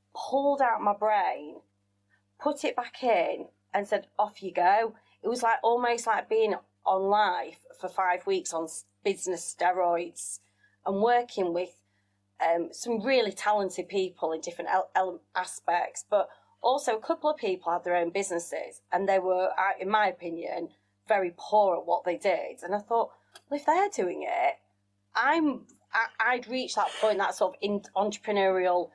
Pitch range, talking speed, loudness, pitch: 175-235 Hz, 170 wpm, -28 LUFS, 195 Hz